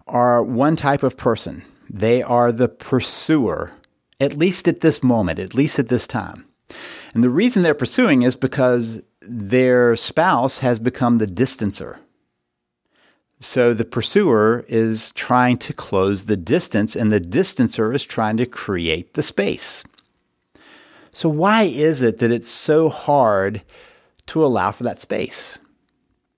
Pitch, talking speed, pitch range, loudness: 120 Hz, 145 wpm, 110-135 Hz, -18 LUFS